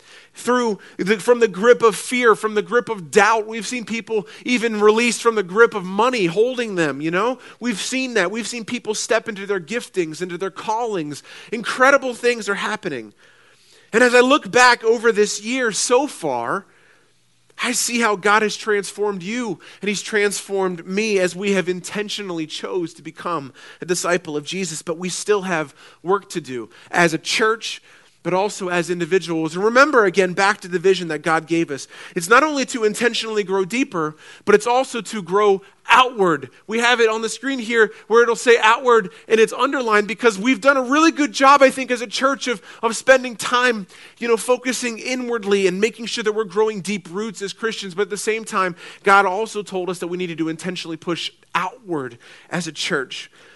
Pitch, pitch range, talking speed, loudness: 215 Hz, 190-240 Hz, 195 wpm, -19 LUFS